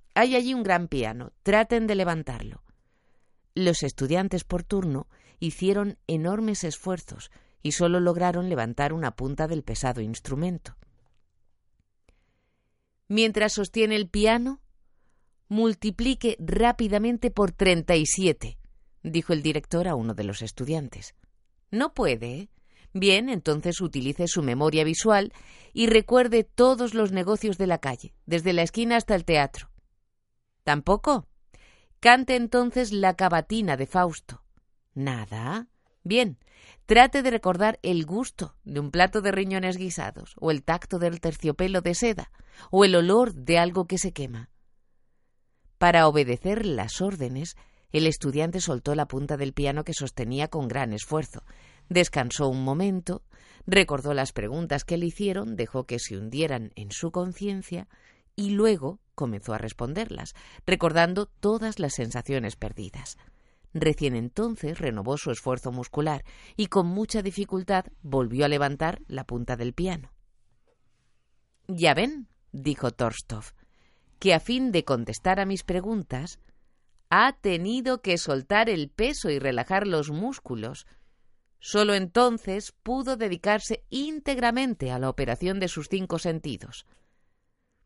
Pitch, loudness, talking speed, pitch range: 170 Hz, -25 LUFS, 130 wpm, 135-205 Hz